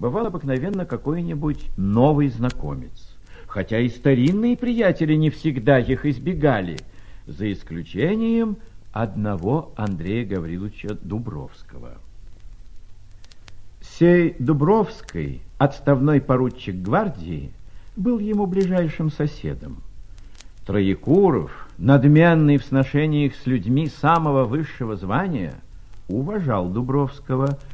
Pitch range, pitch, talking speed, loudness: 100-155 Hz, 130 Hz, 85 wpm, -21 LUFS